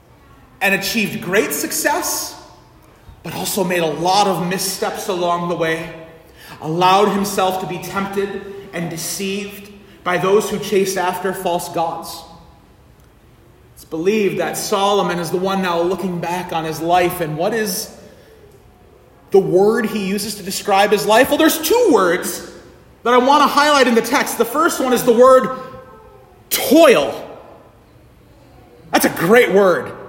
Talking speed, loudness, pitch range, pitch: 150 wpm, -16 LUFS, 175-215 Hz, 195 Hz